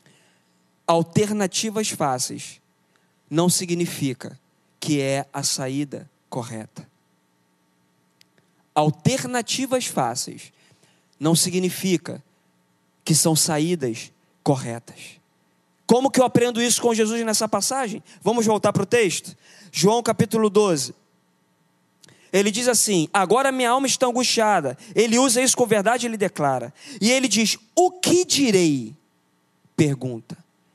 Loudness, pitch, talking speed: -21 LUFS, 175 Hz, 110 wpm